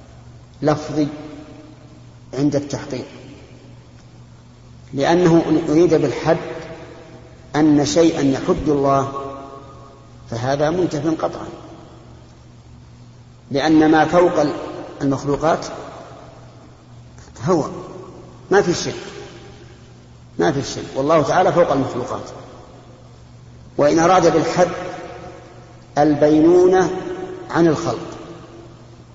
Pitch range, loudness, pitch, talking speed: 130-165 Hz, -17 LUFS, 150 Hz, 75 wpm